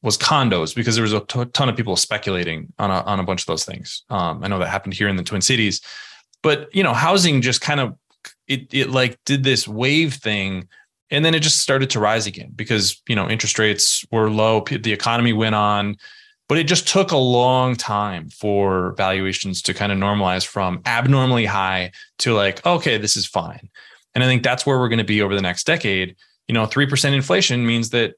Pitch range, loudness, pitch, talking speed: 100-130 Hz, -19 LUFS, 110 Hz, 220 wpm